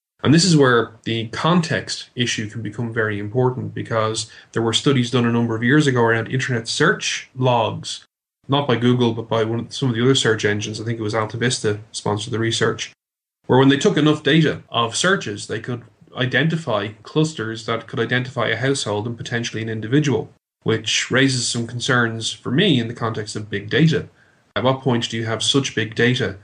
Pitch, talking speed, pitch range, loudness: 120 Hz, 200 wpm, 110-130 Hz, -20 LUFS